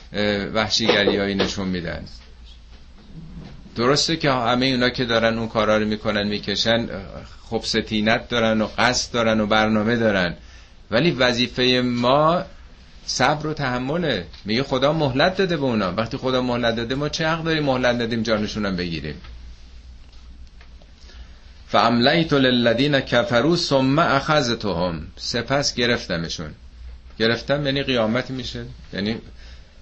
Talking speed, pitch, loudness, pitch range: 120 wpm, 115 Hz, -20 LUFS, 85-125 Hz